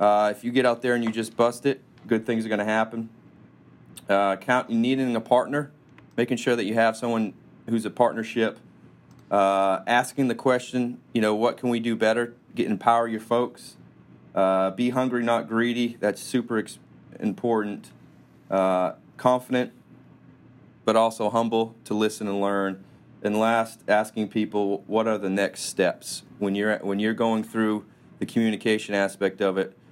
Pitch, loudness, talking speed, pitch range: 115 Hz, -25 LUFS, 165 wpm, 105-120 Hz